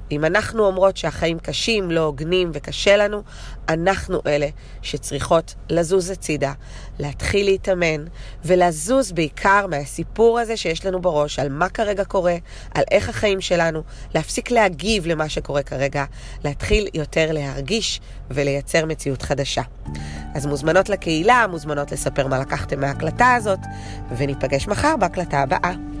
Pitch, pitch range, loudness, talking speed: 160 Hz, 140-195 Hz, -20 LUFS, 125 wpm